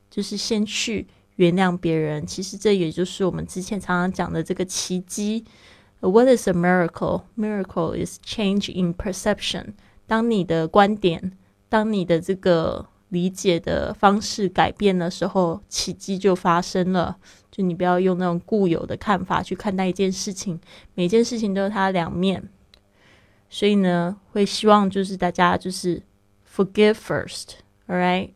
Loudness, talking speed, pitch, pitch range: -22 LUFS, 325 characters per minute, 185 Hz, 175-200 Hz